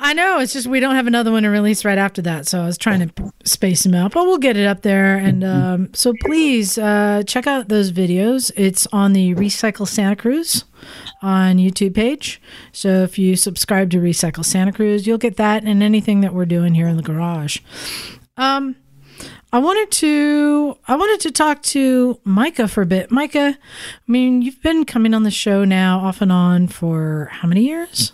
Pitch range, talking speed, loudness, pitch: 185-255 Hz, 205 wpm, -16 LUFS, 210 Hz